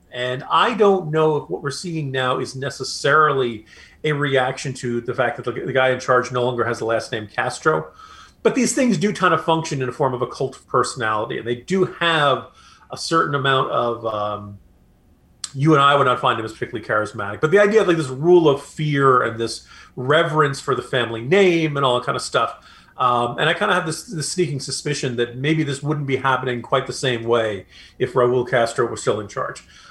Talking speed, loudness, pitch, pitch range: 225 wpm, -20 LUFS, 135 Hz, 120-155 Hz